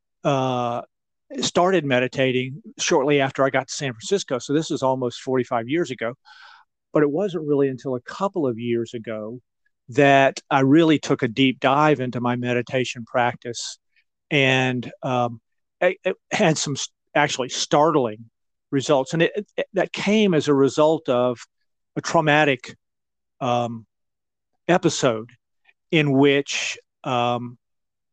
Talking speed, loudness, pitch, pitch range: 135 wpm, -21 LUFS, 135 Hz, 120-155 Hz